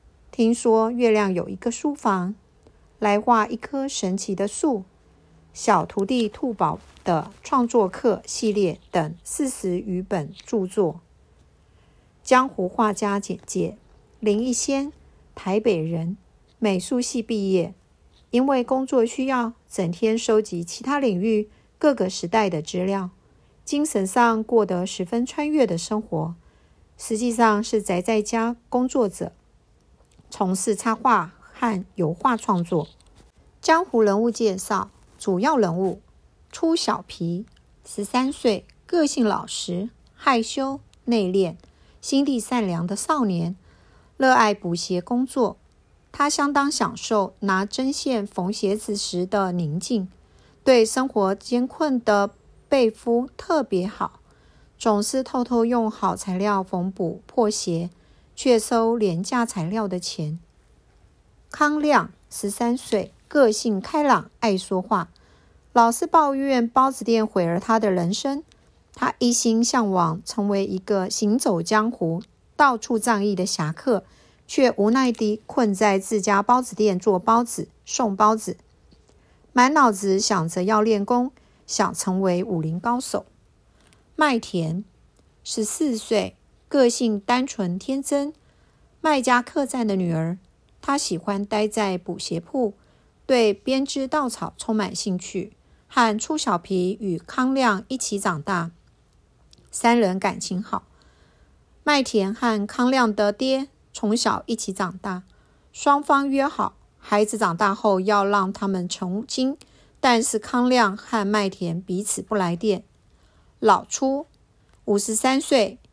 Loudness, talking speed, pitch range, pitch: -23 LUFS, 190 characters per minute, 195-250 Hz, 220 Hz